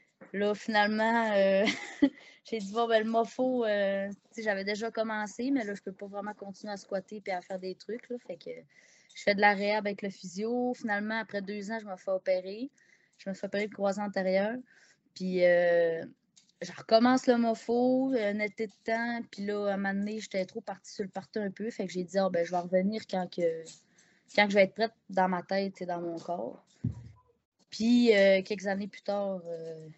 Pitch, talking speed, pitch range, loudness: 205 Hz, 215 wpm, 190-225 Hz, -30 LUFS